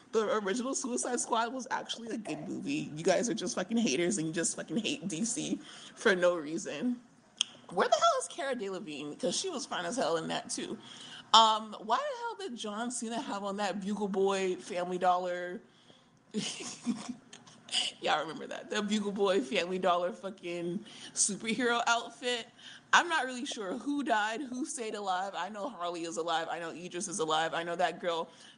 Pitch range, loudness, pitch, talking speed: 180-245 Hz, -32 LUFS, 210 Hz, 185 wpm